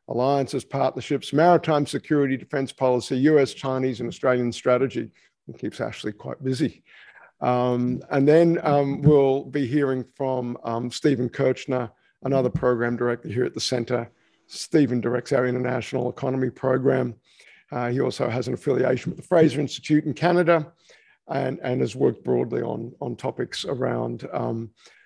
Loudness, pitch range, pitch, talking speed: -23 LUFS, 125-145 Hz, 130 Hz, 150 wpm